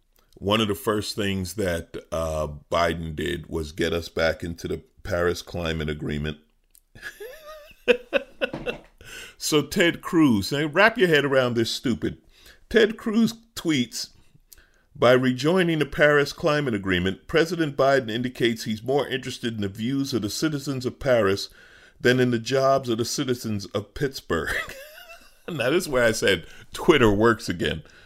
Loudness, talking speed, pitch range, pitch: -24 LUFS, 150 wpm, 95-155 Hz, 125 Hz